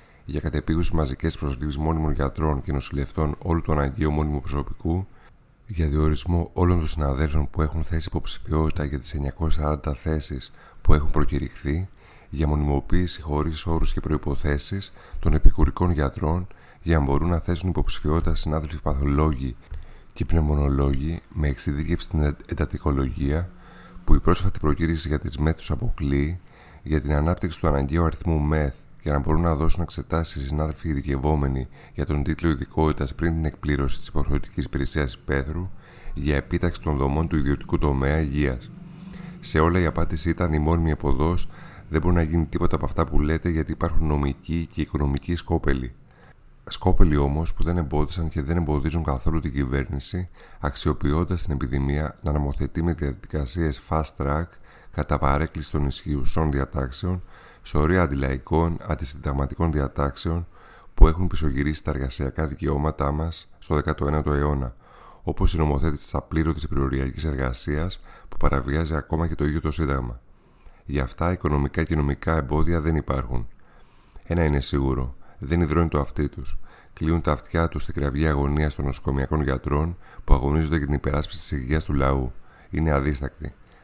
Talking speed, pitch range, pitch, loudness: 150 wpm, 70-85 Hz, 75 Hz, -25 LUFS